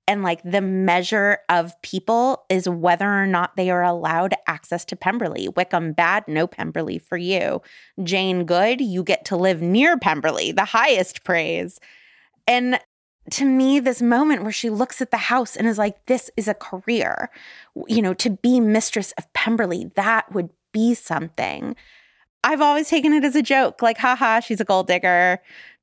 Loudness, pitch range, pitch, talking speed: -20 LUFS, 180-240 Hz, 205 Hz, 175 wpm